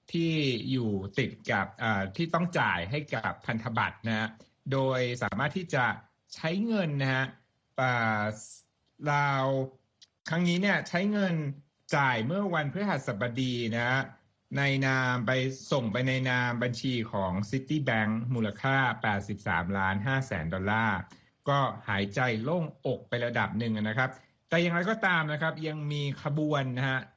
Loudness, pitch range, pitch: -30 LUFS, 110-145 Hz, 130 Hz